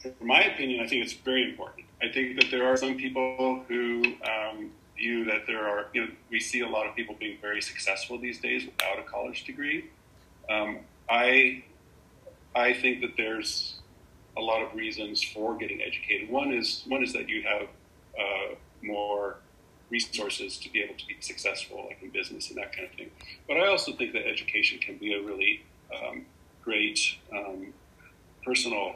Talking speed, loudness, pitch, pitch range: 185 wpm, -28 LUFS, 120 Hz, 105-130 Hz